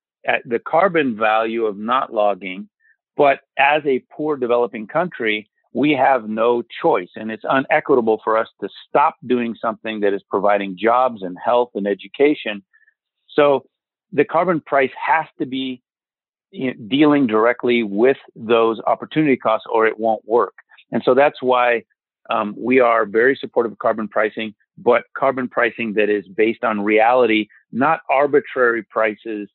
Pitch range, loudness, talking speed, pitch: 110-130 Hz, -18 LUFS, 150 wpm, 115 Hz